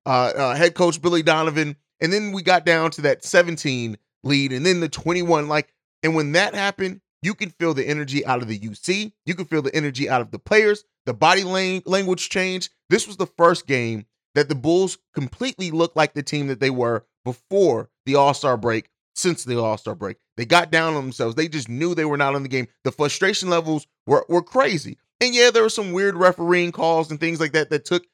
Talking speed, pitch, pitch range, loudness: 225 wpm, 160 Hz, 140-180 Hz, -21 LUFS